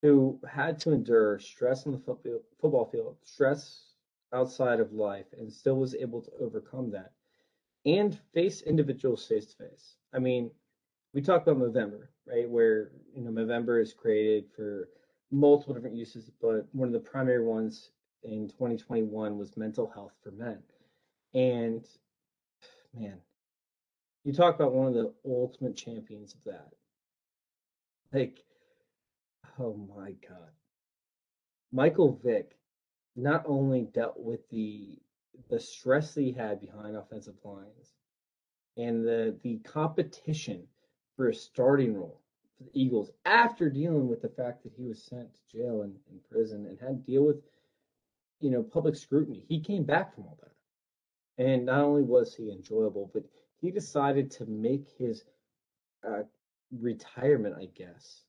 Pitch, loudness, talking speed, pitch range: 125 Hz, -30 LUFS, 145 wpm, 110-145 Hz